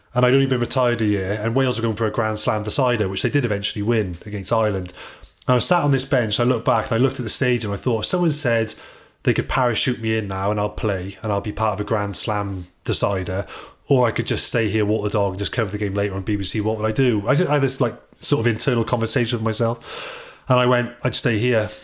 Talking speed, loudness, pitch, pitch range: 280 wpm, -20 LUFS, 115 Hz, 105-125 Hz